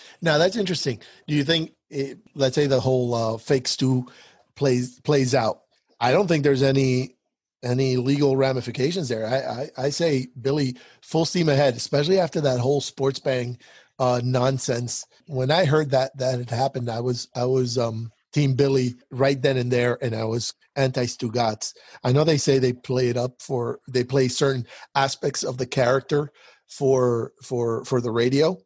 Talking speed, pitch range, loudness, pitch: 180 wpm, 125-140 Hz, -23 LUFS, 130 Hz